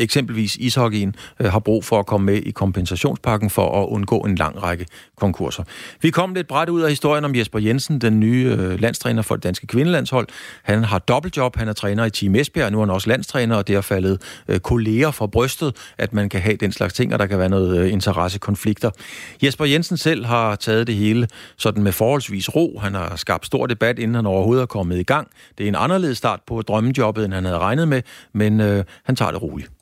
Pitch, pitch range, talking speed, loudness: 110 Hz, 100-125 Hz, 215 wpm, -19 LUFS